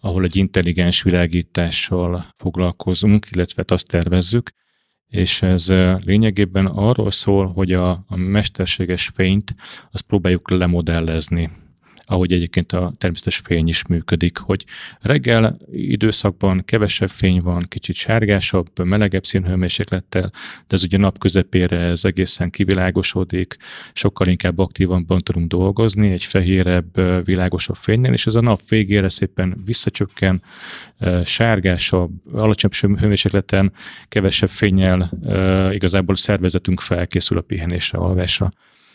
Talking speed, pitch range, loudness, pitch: 110 wpm, 90-100 Hz, -18 LUFS, 95 Hz